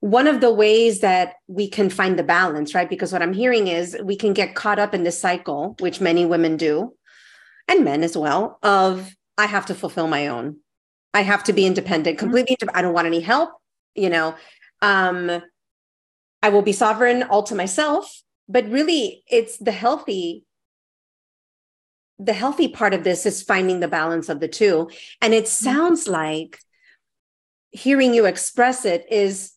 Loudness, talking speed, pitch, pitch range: -19 LUFS, 175 wpm, 195 Hz, 170-230 Hz